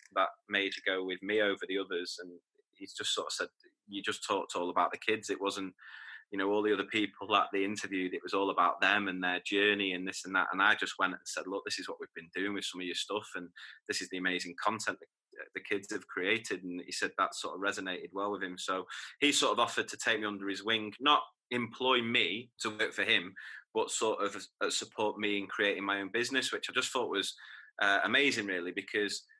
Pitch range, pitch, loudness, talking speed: 95-130 Hz, 105 Hz, -32 LUFS, 245 wpm